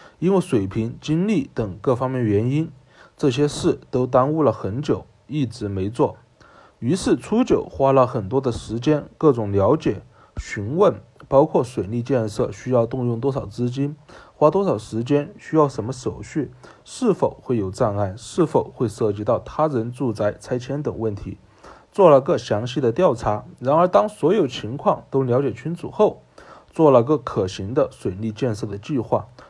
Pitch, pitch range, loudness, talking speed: 125 Hz, 110-145 Hz, -21 LUFS, 250 characters per minute